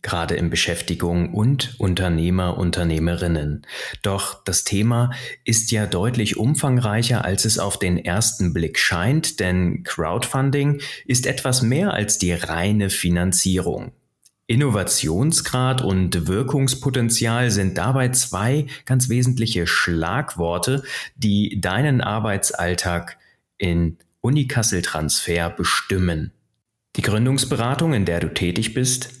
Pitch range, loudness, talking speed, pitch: 85-125 Hz, -20 LUFS, 105 wpm, 105 Hz